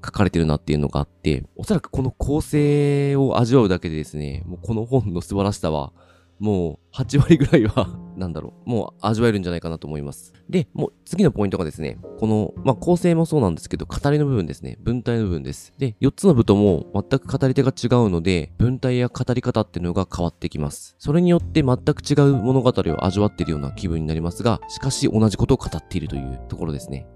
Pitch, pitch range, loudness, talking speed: 105 Hz, 85-135 Hz, -21 LUFS, 455 characters per minute